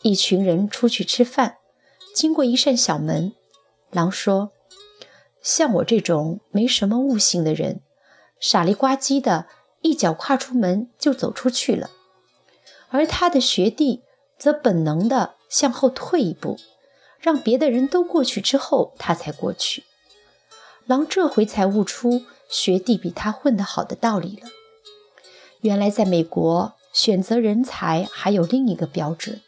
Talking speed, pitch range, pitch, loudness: 205 characters per minute, 190-270 Hz, 235 Hz, -20 LUFS